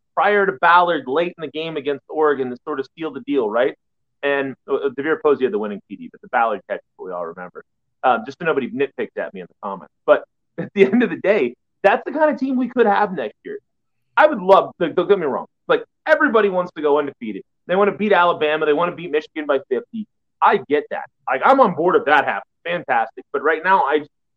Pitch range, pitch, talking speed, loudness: 155-255 Hz, 195 Hz, 245 wpm, -19 LUFS